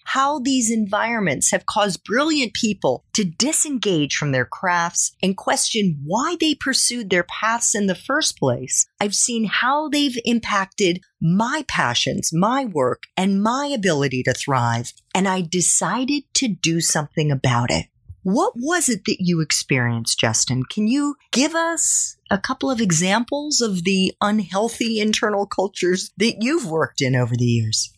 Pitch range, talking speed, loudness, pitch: 170-250 Hz, 155 wpm, -19 LUFS, 205 Hz